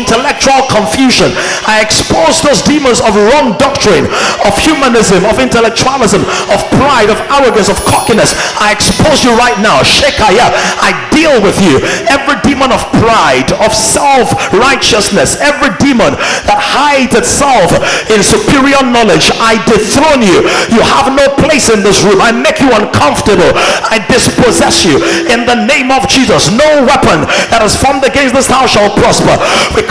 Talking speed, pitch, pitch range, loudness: 155 wpm, 260 Hz, 225-275 Hz, -6 LUFS